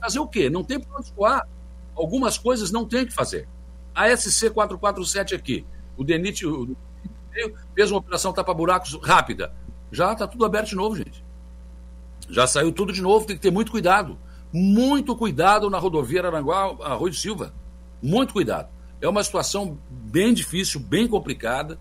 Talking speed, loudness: 160 wpm, -22 LUFS